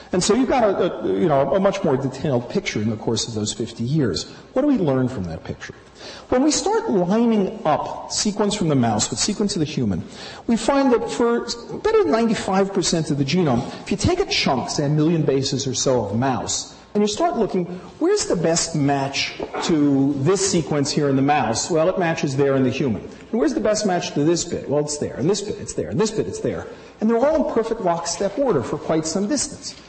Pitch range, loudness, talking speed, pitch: 140-215 Hz, -21 LUFS, 235 wpm, 170 Hz